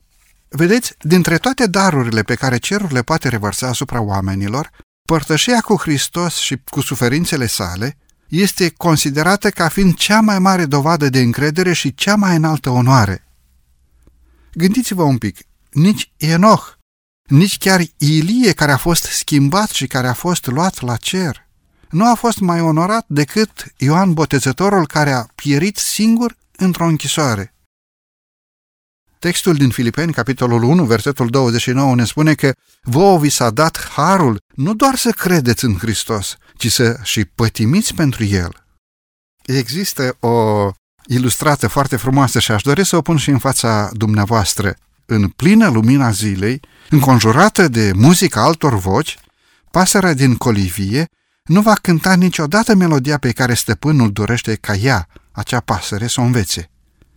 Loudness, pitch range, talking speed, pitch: -14 LUFS, 115-170 Hz, 145 wpm, 140 Hz